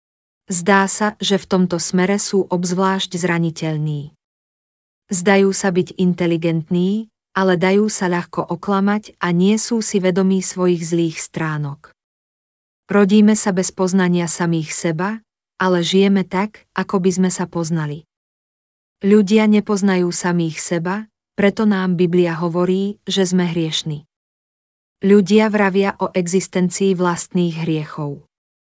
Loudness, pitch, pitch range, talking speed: -17 LUFS, 185 Hz, 170-195 Hz, 120 wpm